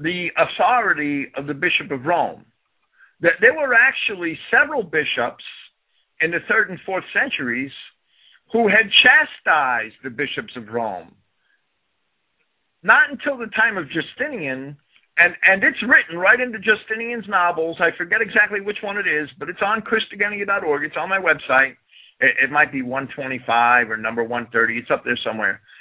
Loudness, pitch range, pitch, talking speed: -18 LUFS, 145-225 Hz, 180 Hz, 155 wpm